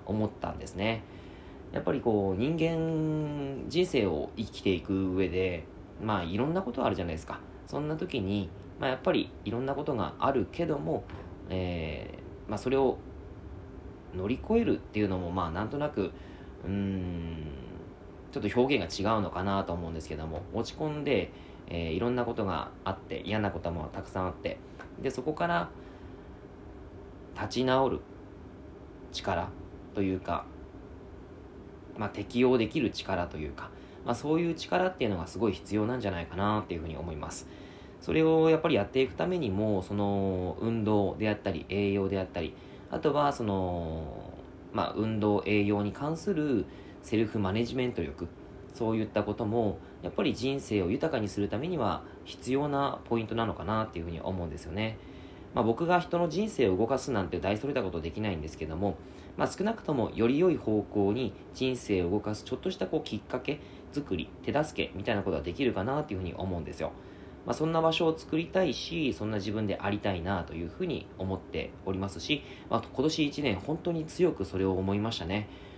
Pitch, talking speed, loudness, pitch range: 100 Hz, 365 characters per minute, -31 LUFS, 95-125 Hz